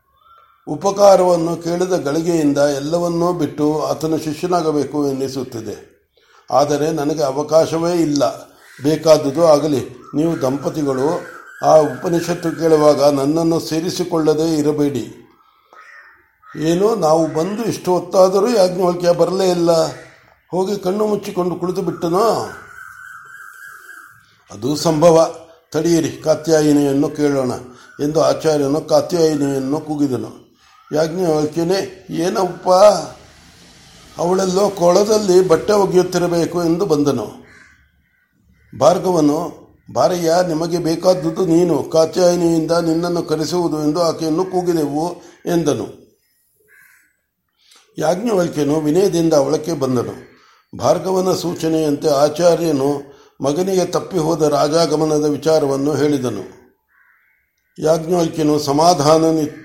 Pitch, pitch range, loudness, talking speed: 160 Hz, 150-175 Hz, -16 LUFS, 80 wpm